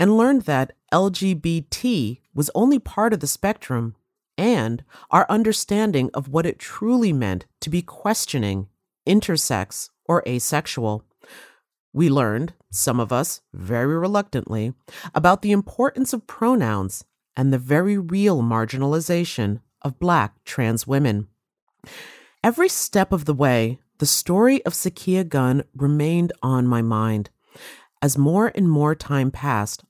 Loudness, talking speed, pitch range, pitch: -21 LUFS, 130 wpm, 120-190 Hz, 145 Hz